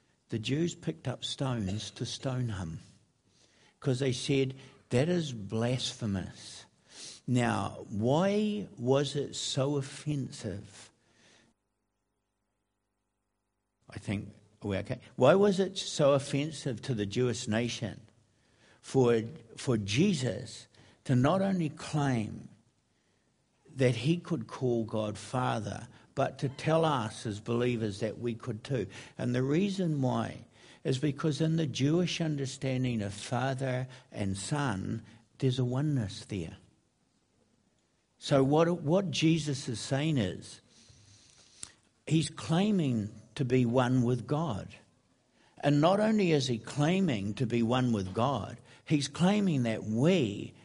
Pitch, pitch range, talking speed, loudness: 125 Hz, 110-145 Hz, 120 wpm, -31 LUFS